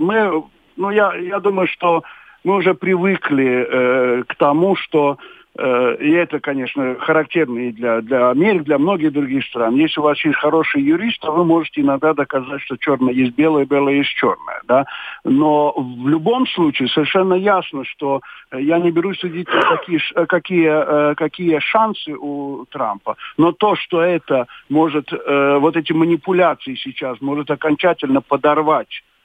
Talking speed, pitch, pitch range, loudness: 160 wpm, 155 Hz, 140-180 Hz, -17 LUFS